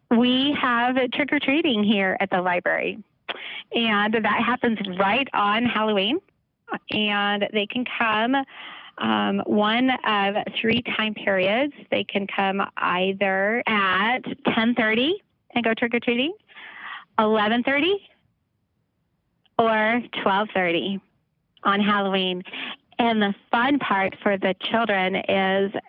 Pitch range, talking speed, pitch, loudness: 195-245 Hz, 105 wpm, 215 Hz, -22 LUFS